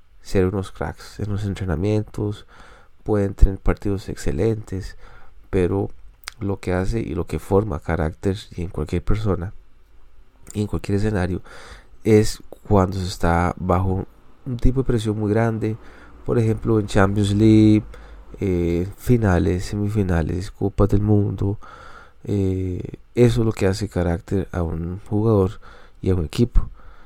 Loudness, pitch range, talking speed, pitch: -22 LUFS, 90-105 Hz, 135 wpm, 100 Hz